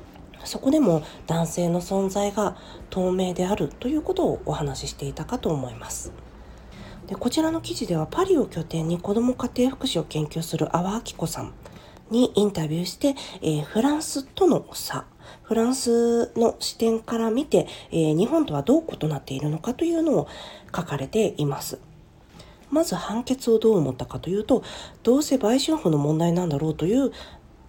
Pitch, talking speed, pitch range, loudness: 195 Hz, 340 characters per minute, 155-245 Hz, -24 LUFS